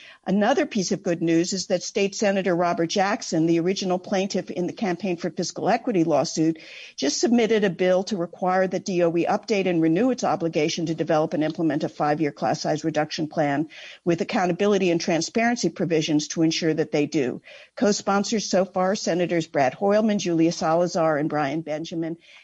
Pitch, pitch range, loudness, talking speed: 175 Hz, 165-195 Hz, -23 LUFS, 175 wpm